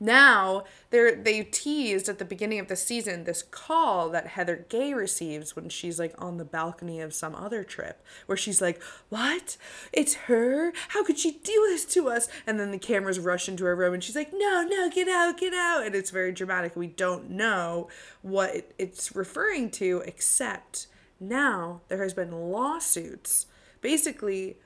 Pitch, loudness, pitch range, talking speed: 200 Hz, -27 LUFS, 180-285 Hz, 180 wpm